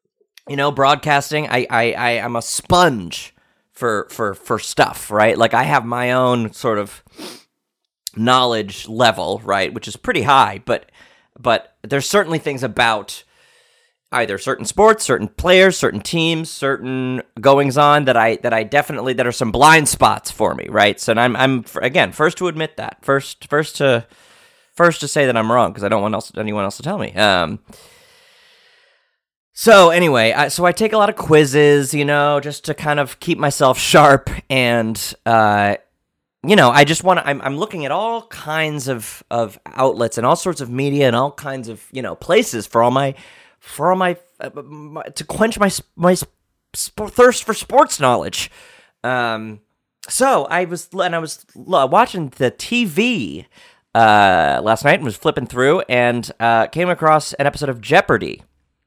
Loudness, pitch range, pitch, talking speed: -16 LUFS, 125-175 Hz, 145 Hz, 180 wpm